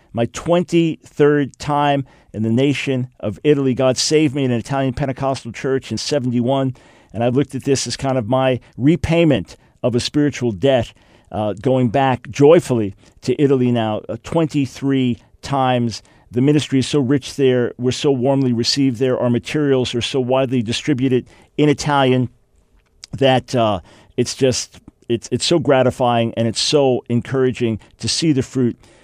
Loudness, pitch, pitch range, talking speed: -18 LUFS, 130 Hz, 120-140 Hz, 160 wpm